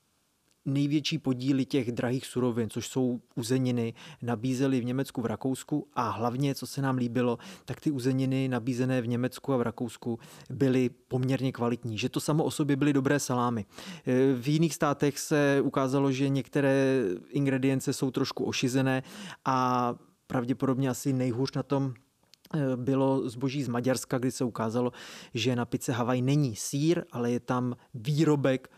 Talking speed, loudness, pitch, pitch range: 150 wpm, -29 LUFS, 130 Hz, 125-140 Hz